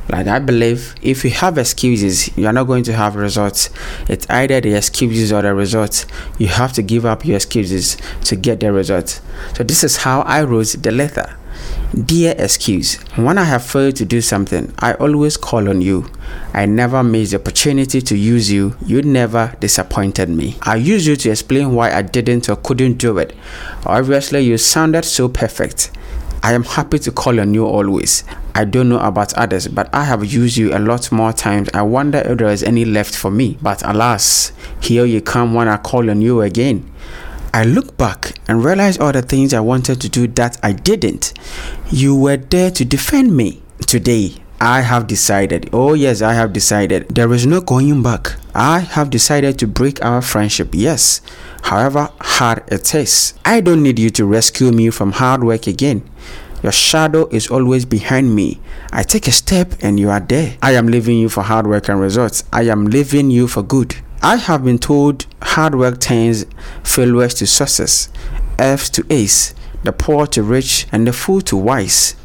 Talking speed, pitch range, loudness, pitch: 195 wpm, 105-135 Hz, -14 LUFS, 120 Hz